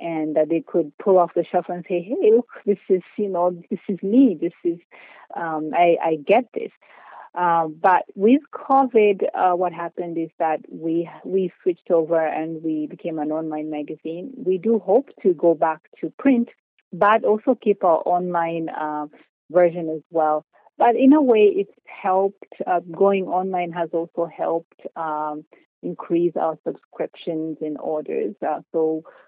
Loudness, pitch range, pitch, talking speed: -21 LUFS, 160-195 Hz, 175 Hz, 170 wpm